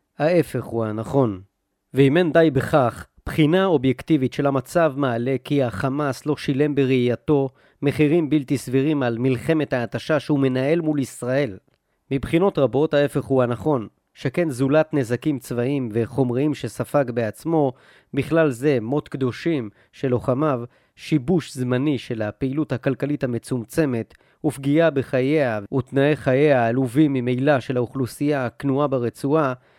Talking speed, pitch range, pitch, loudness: 125 wpm, 125-150 Hz, 135 Hz, -21 LUFS